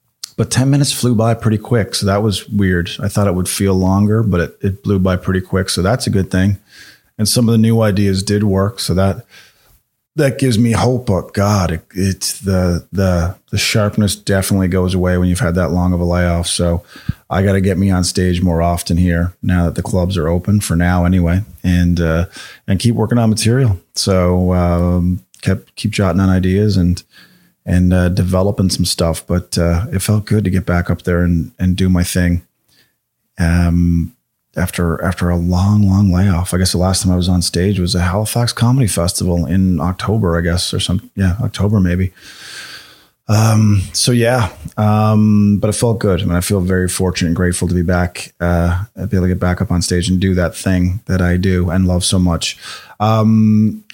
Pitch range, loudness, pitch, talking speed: 90-105 Hz, -15 LUFS, 95 Hz, 210 wpm